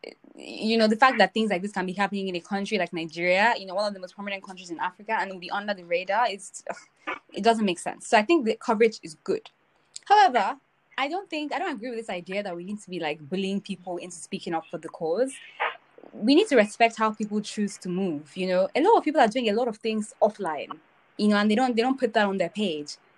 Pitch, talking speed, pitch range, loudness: 205 Hz, 265 wpm, 185-240 Hz, -25 LUFS